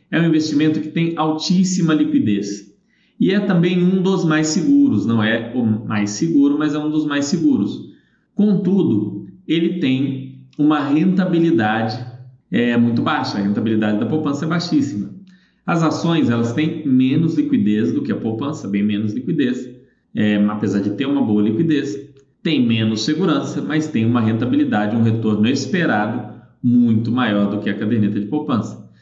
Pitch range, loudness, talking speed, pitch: 110-160 Hz, -18 LUFS, 160 wpm, 140 Hz